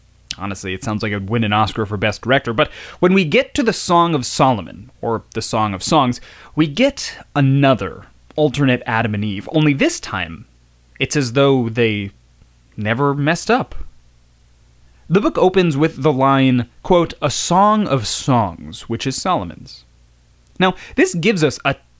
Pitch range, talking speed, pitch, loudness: 100-155 Hz, 165 wpm, 120 Hz, -17 LUFS